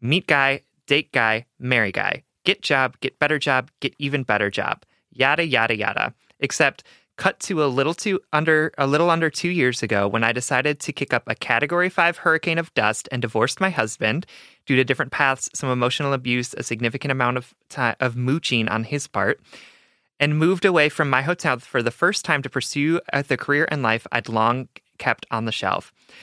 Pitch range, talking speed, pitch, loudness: 120-155 Hz, 195 wpm, 135 Hz, -21 LUFS